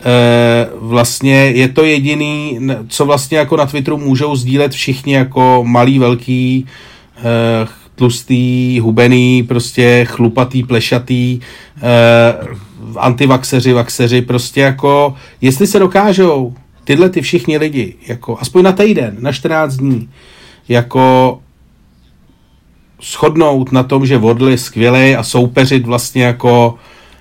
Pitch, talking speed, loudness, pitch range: 125 Hz, 115 wpm, -11 LUFS, 120-135 Hz